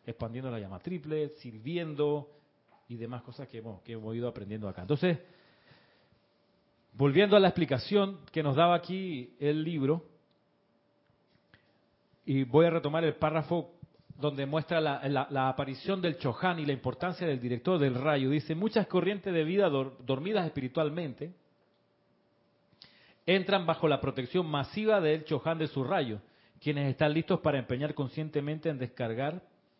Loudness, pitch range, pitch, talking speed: -31 LUFS, 135-170 Hz, 150 Hz, 145 wpm